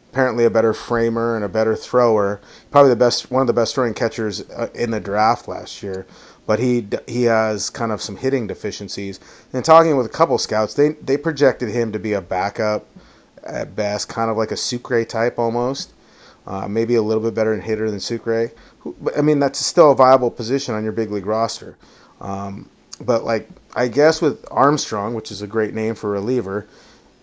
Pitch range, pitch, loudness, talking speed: 110-125 Hz, 115 Hz, -19 LUFS, 205 wpm